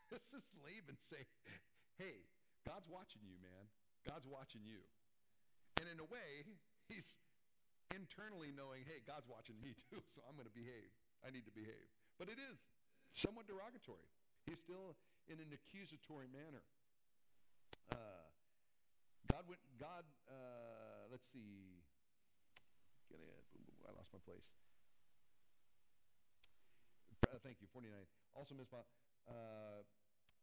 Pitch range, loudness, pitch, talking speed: 105-145 Hz, -55 LUFS, 120 Hz, 135 wpm